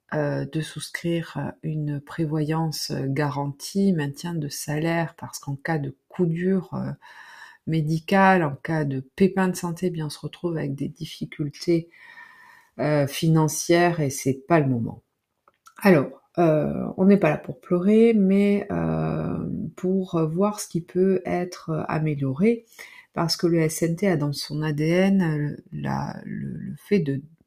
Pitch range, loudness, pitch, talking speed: 145-185 Hz, -24 LUFS, 160 Hz, 150 wpm